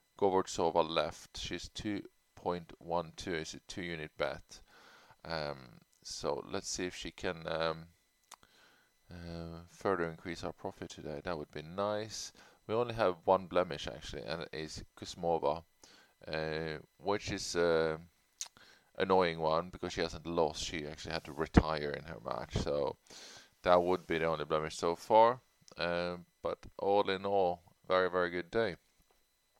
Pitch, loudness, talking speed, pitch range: 85 Hz, -35 LUFS, 150 wpm, 80-90 Hz